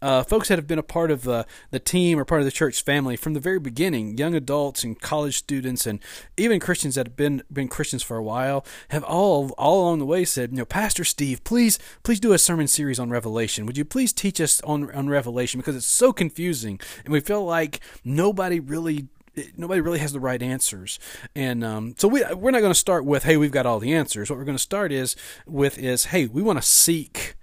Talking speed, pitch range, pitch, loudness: 240 wpm, 130-170 Hz, 145 Hz, -22 LUFS